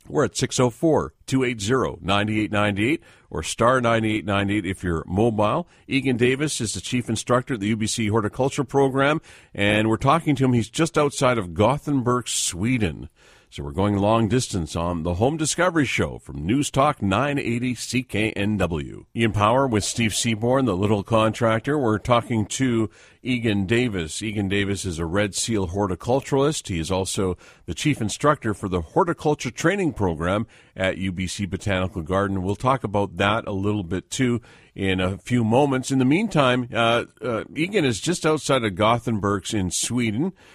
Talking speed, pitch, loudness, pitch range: 160 wpm, 110 Hz, -22 LUFS, 100-130 Hz